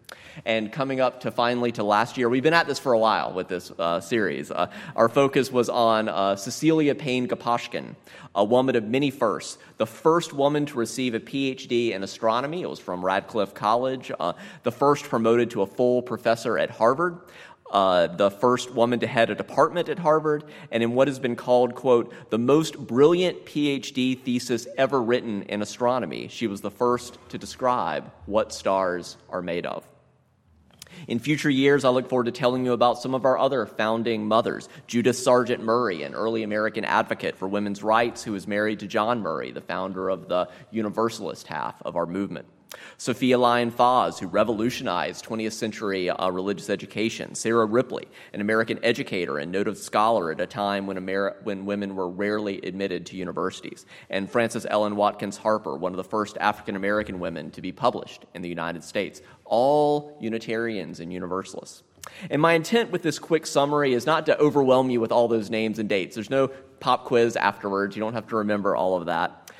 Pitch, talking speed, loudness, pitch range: 115 Hz, 190 wpm, -24 LUFS, 105-130 Hz